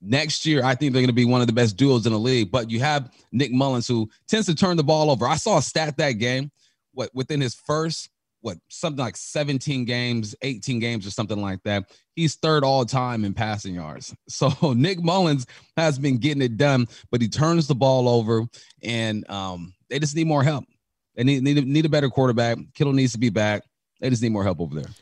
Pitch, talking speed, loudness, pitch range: 130 Hz, 235 wpm, -22 LUFS, 115-145 Hz